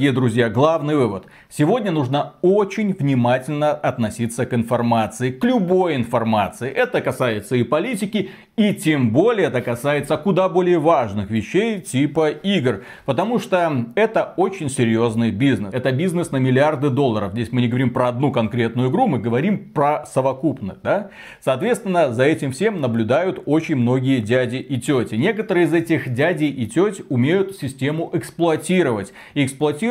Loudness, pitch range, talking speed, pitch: -19 LUFS, 125-175 Hz, 150 wpm, 145 Hz